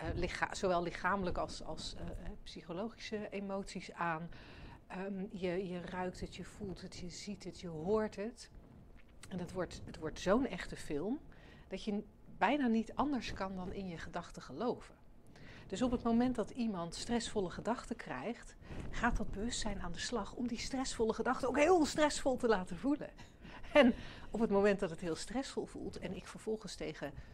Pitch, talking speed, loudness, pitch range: 200 Hz, 175 wpm, -38 LUFS, 180-235 Hz